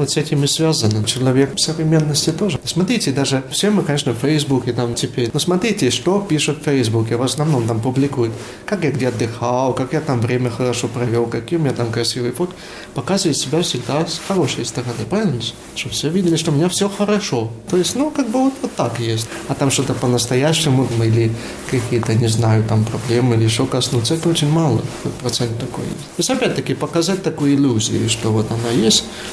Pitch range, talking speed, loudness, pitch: 120-160 Hz, 195 wpm, -18 LUFS, 135 Hz